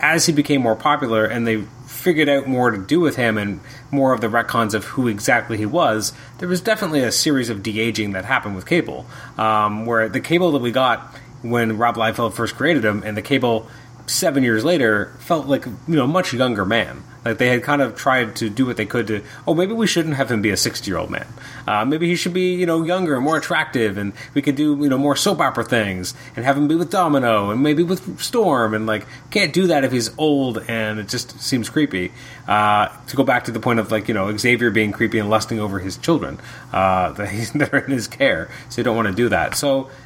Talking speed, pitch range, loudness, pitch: 245 wpm, 110-140 Hz, -19 LUFS, 125 Hz